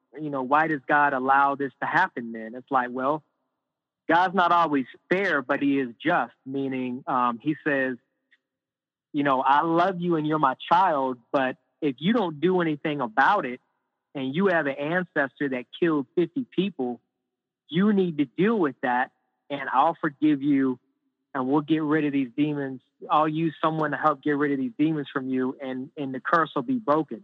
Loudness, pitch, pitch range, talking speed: -25 LUFS, 145 Hz, 130-155 Hz, 190 wpm